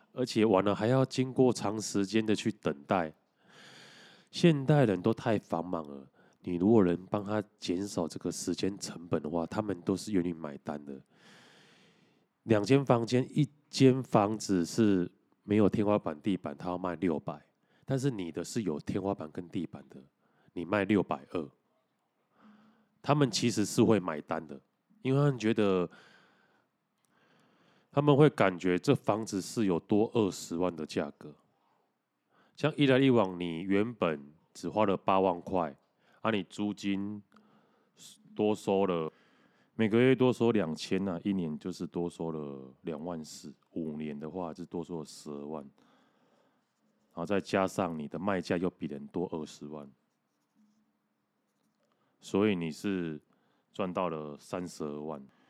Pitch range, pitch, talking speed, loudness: 85-115 Hz, 100 Hz, 210 characters per minute, -31 LUFS